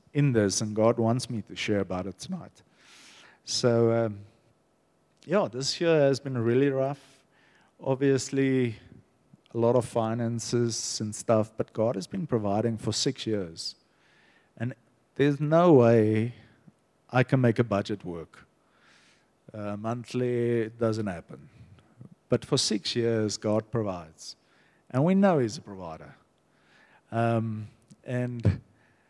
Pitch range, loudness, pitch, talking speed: 110-130 Hz, -27 LUFS, 115 Hz, 130 wpm